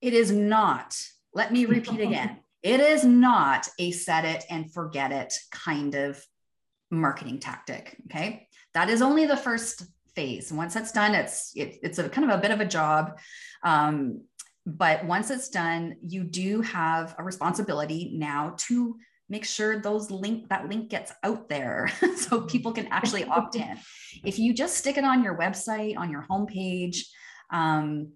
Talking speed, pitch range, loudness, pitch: 170 wpm, 165-230 Hz, -26 LUFS, 200 Hz